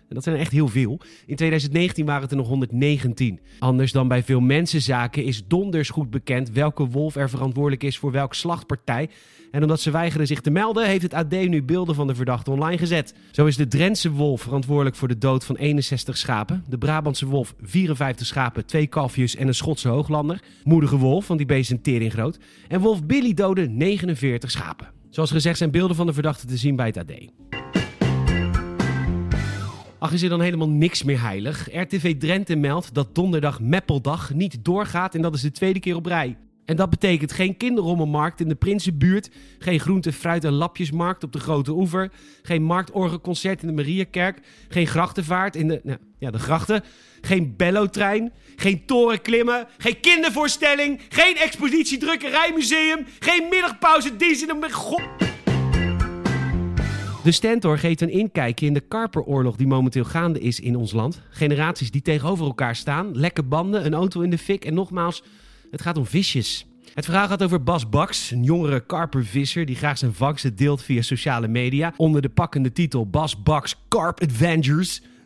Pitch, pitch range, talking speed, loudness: 155 Hz, 135-180 Hz, 175 wpm, -22 LUFS